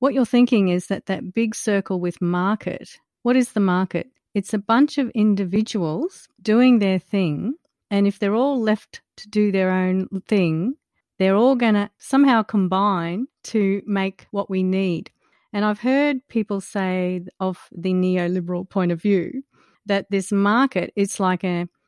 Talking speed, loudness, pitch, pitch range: 165 wpm, -21 LUFS, 200 Hz, 185-225 Hz